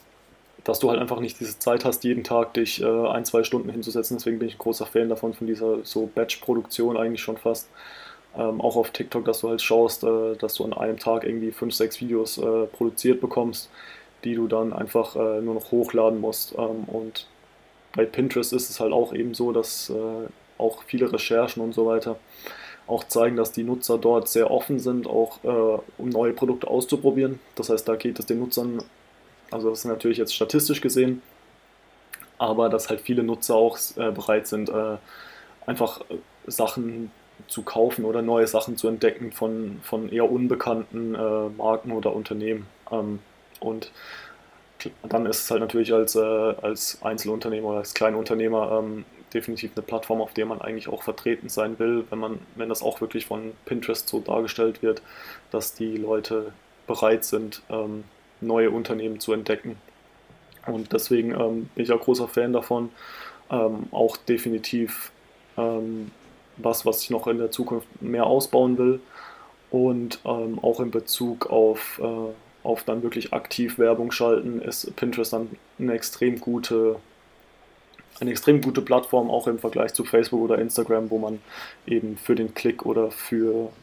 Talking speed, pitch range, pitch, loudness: 170 wpm, 110-120 Hz, 115 Hz, -25 LUFS